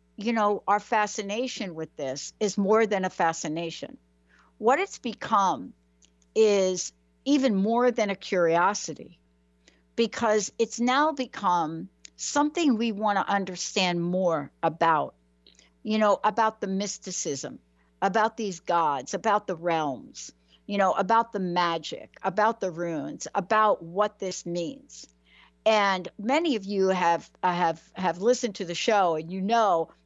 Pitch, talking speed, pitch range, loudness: 190 Hz, 135 wpm, 165-215 Hz, -26 LUFS